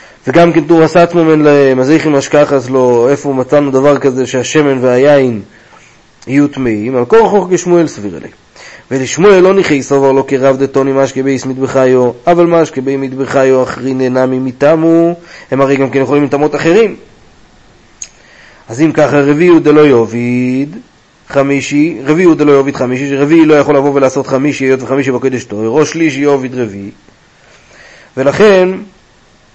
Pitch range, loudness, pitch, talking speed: 130-155 Hz, -9 LUFS, 140 Hz, 155 wpm